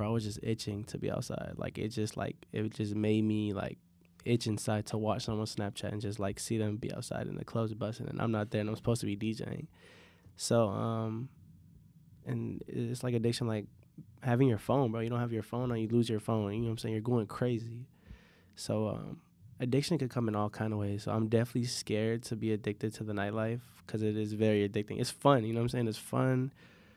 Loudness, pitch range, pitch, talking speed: -34 LUFS, 105-120 Hz, 110 Hz, 235 wpm